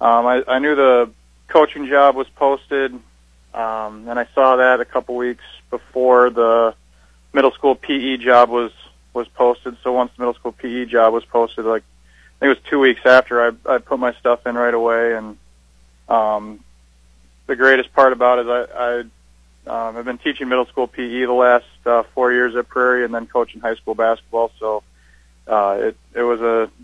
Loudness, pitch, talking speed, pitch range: -17 LUFS, 120 Hz, 190 wpm, 110-125 Hz